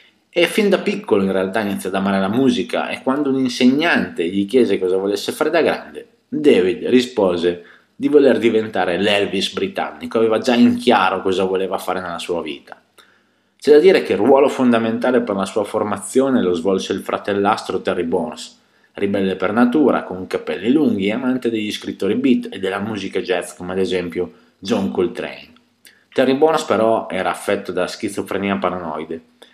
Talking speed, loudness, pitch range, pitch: 170 wpm, -18 LUFS, 95-125 Hz, 100 Hz